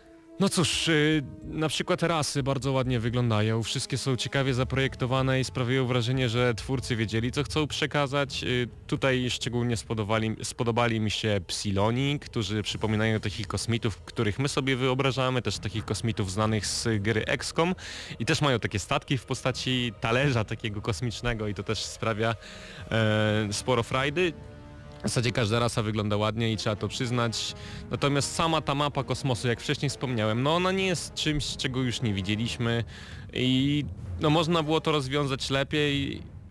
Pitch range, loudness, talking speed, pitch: 110-140 Hz, -27 LUFS, 155 wpm, 125 Hz